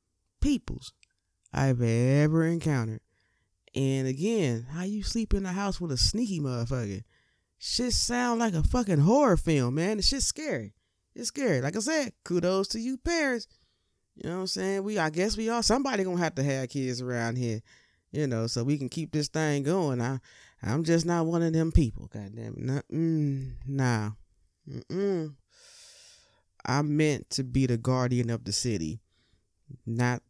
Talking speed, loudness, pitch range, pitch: 170 wpm, -28 LUFS, 120-195 Hz, 145 Hz